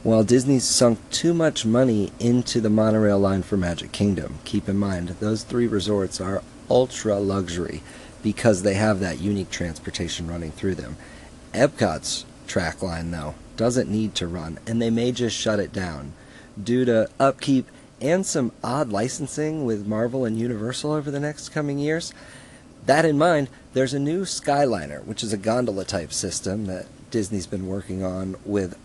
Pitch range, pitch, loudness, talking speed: 95-130 Hz, 110 Hz, -23 LUFS, 170 wpm